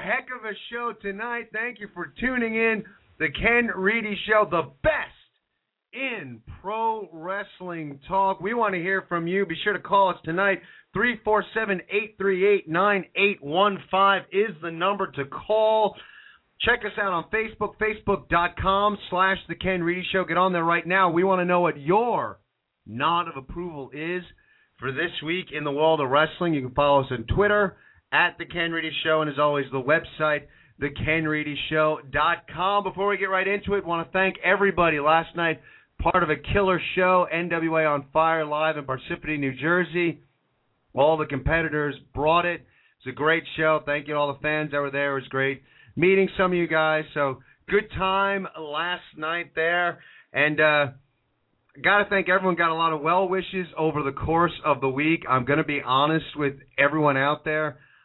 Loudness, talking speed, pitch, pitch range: -24 LUFS, 180 wpm, 170 Hz, 150-195 Hz